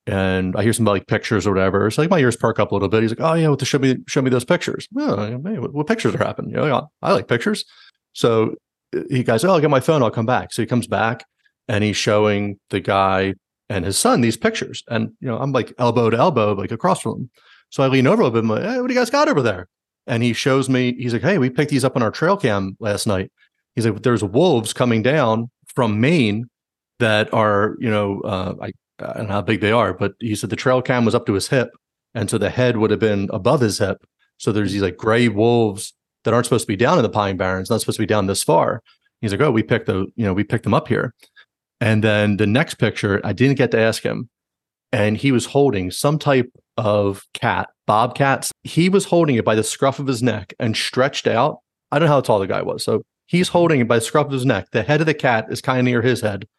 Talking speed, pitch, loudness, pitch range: 265 wpm, 115 Hz, -19 LUFS, 105-130 Hz